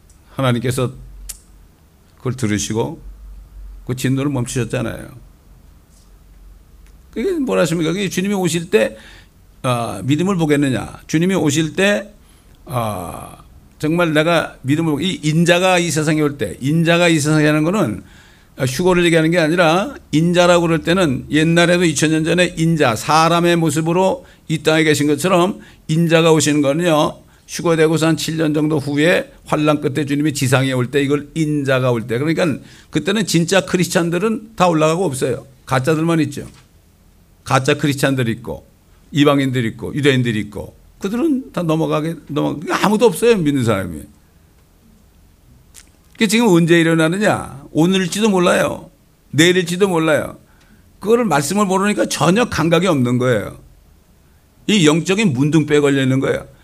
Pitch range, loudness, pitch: 120-170 Hz, -16 LUFS, 150 Hz